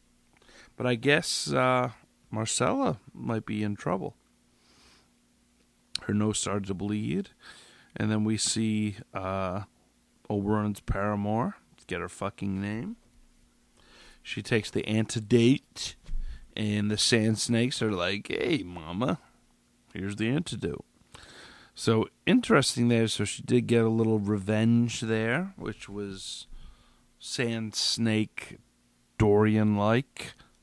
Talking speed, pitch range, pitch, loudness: 110 wpm, 95-115 Hz, 105 Hz, -28 LUFS